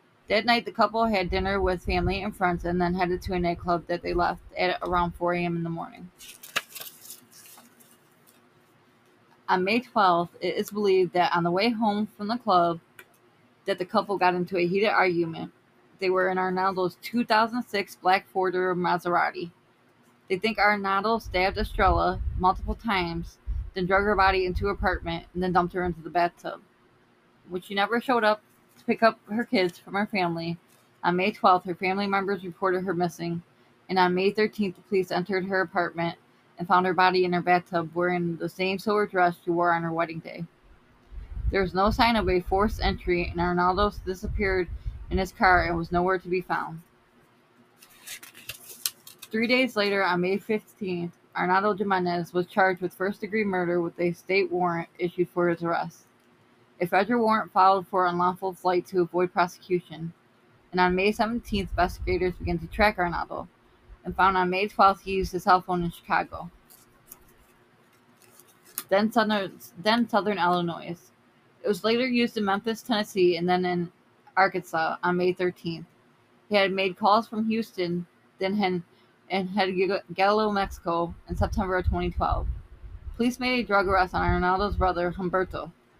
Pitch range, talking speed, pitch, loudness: 175-200 Hz, 170 wpm, 185 Hz, -26 LUFS